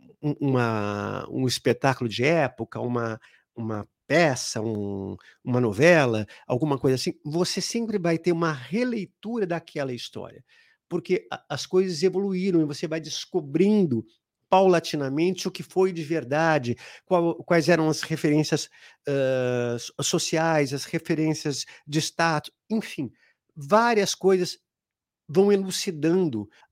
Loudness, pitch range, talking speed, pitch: -25 LUFS, 130-180 Hz, 120 wpm, 160 Hz